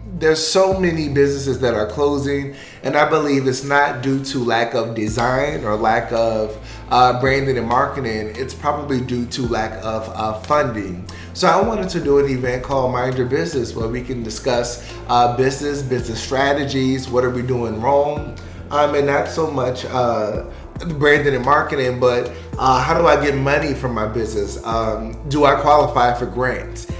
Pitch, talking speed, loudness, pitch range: 130 Hz, 180 wpm, -18 LUFS, 115-140 Hz